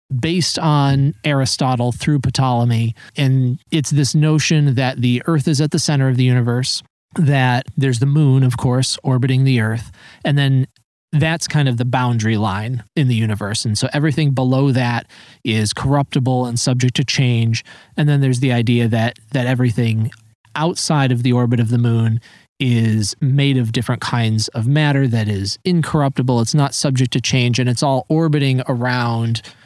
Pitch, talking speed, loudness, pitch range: 130 Hz, 170 wpm, -17 LUFS, 120-140 Hz